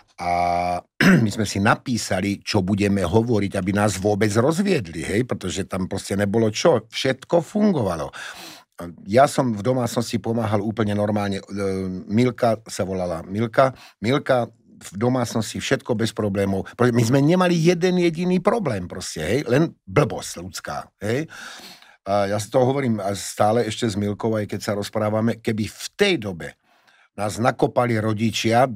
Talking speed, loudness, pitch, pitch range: 140 wpm, -22 LUFS, 110 Hz, 100-125 Hz